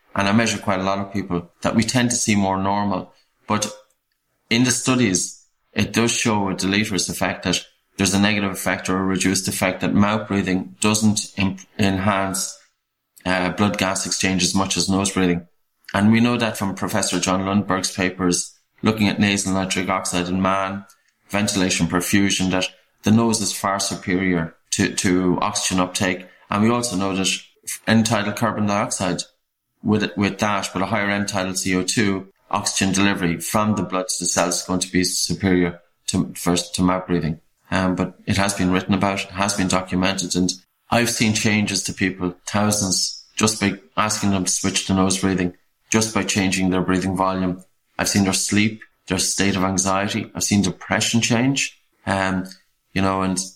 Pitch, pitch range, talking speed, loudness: 95 Hz, 95-105 Hz, 180 wpm, -20 LUFS